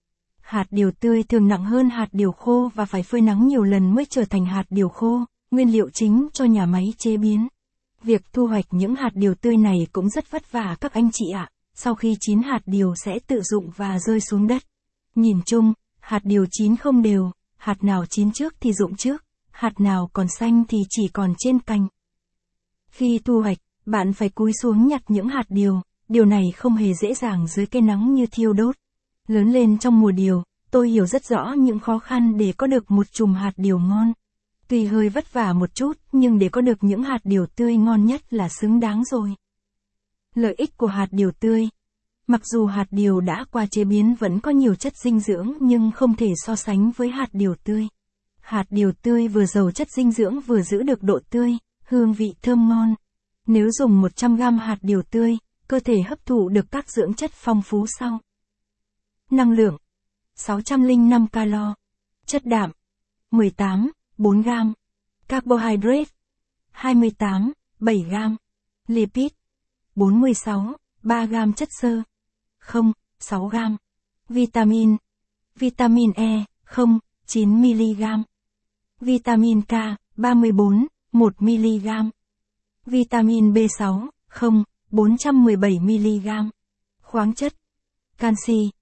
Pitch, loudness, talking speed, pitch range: 220 Hz, -20 LUFS, 165 wpm, 200-235 Hz